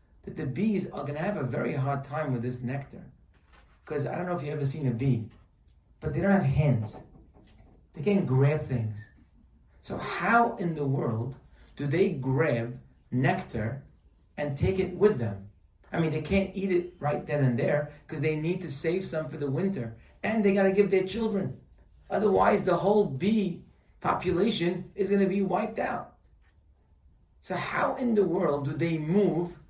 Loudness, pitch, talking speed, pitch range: -28 LUFS, 155 Hz, 180 wpm, 125-190 Hz